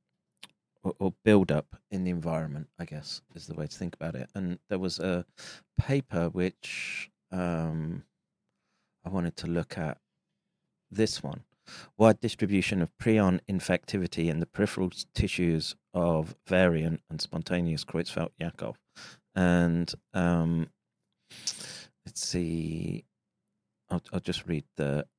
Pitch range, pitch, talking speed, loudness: 85-95 Hz, 90 Hz, 125 wpm, -30 LUFS